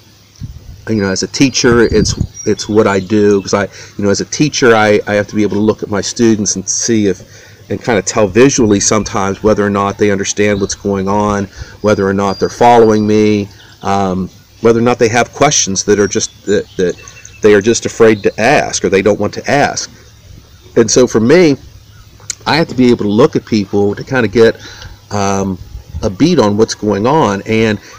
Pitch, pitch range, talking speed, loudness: 105 Hz, 100-110 Hz, 215 wpm, -12 LUFS